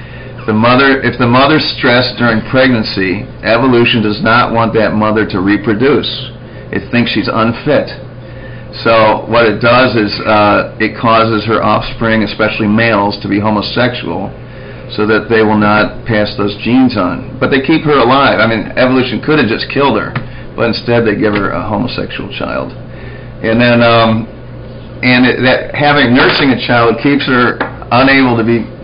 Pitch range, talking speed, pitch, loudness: 110-130 Hz, 170 wpm, 120 Hz, -10 LUFS